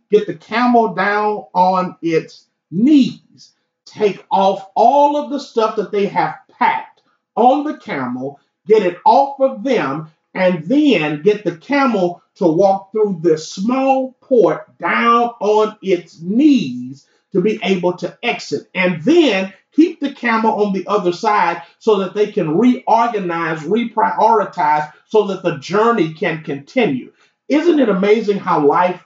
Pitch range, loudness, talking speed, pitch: 180-240 Hz, -16 LUFS, 145 wpm, 210 Hz